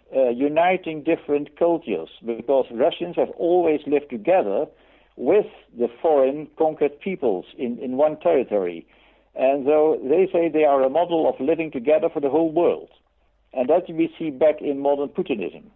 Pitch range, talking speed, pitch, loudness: 140-170 Hz, 160 wpm, 155 Hz, -22 LUFS